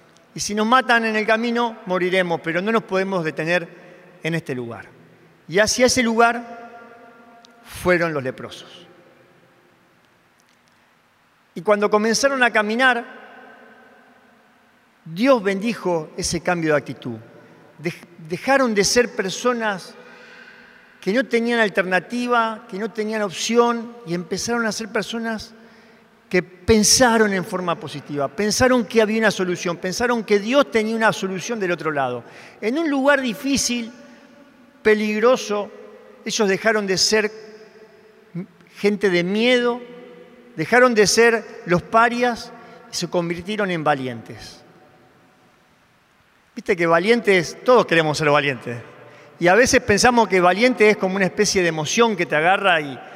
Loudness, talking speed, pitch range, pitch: -19 LUFS, 130 wpm, 180-235 Hz, 215 Hz